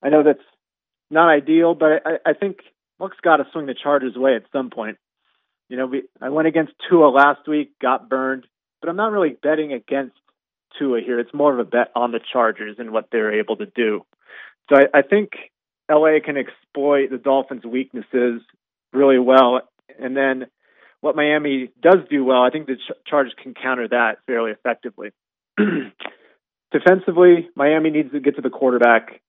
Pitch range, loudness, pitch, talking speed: 125-155 Hz, -18 LUFS, 140 Hz, 185 wpm